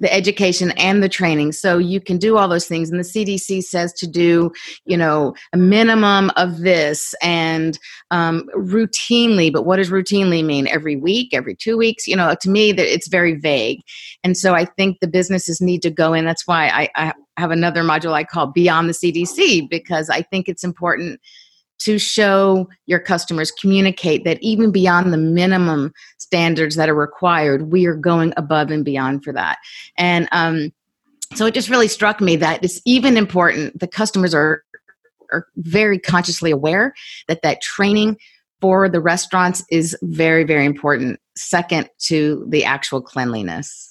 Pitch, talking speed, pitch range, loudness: 175 Hz, 180 wpm, 160-195 Hz, -16 LUFS